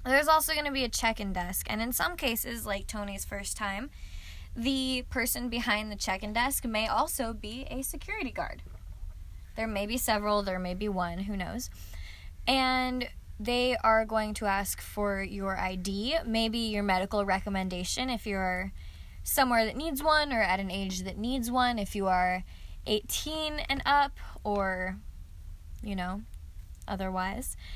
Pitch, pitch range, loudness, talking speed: 205 Hz, 185-245 Hz, -30 LUFS, 165 wpm